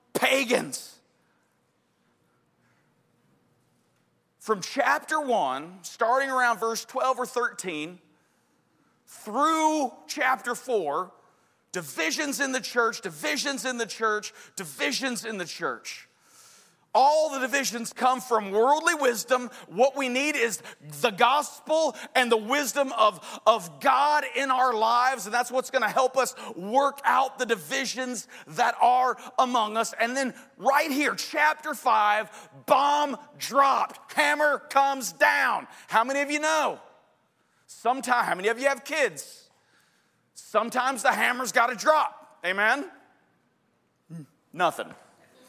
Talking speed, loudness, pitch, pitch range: 120 wpm, -25 LUFS, 255 Hz, 225-280 Hz